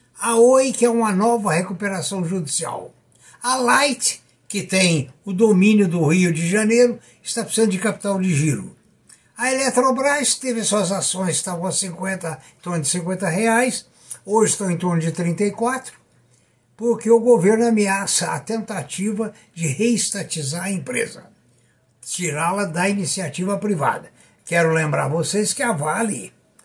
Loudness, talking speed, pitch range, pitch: -20 LUFS, 145 wpm, 170-225 Hz, 195 Hz